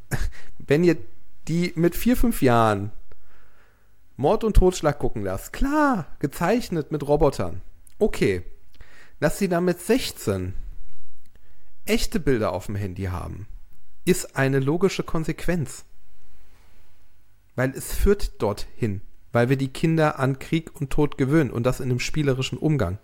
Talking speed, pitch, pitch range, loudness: 135 wpm, 130 Hz, 100-165 Hz, -24 LUFS